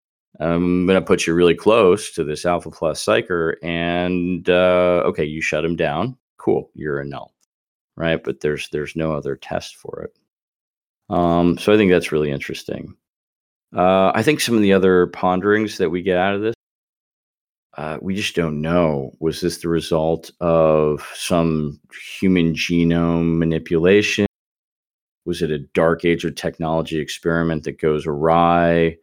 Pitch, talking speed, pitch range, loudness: 85 Hz, 160 wpm, 80-90 Hz, -19 LUFS